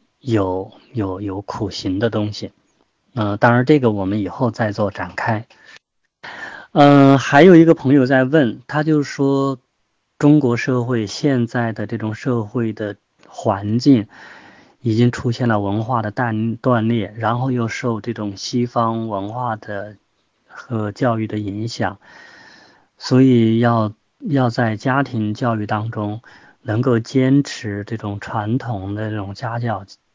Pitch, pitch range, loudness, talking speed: 115 Hz, 105-125 Hz, -18 LUFS, 200 characters per minute